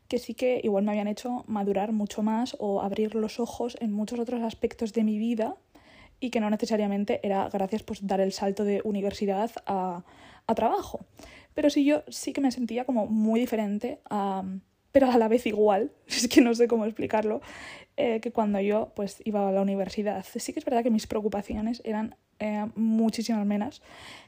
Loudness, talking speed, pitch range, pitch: -28 LUFS, 195 wpm, 205-235 Hz, 220 Hz